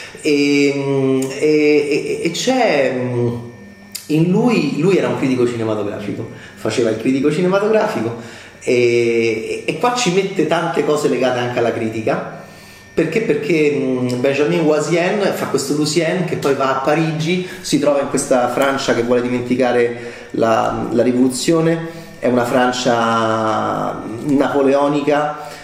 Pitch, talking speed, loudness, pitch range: 135 Hz, 125 wpm, -17 LUFS, 120-155 Hz